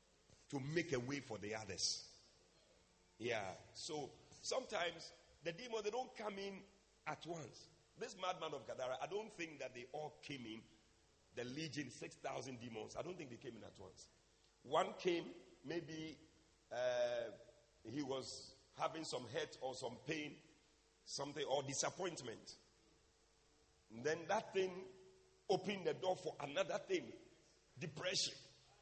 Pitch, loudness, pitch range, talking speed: 155 Hz, -45 LUFS, 135-185 Hz, 140 wpm